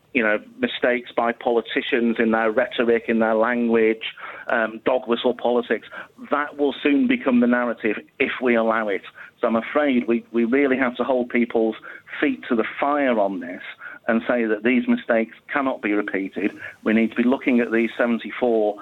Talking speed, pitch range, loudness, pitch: 180 wpm, 115-125 Hz, -21 LUFS, 120 Hz